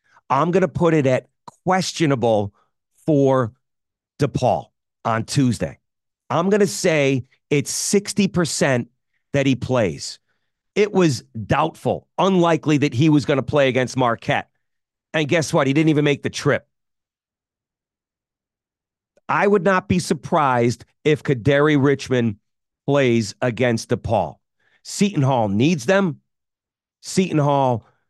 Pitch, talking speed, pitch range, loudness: 140 Hz, 115 wpm, 120-165 Hz, -20 LUFS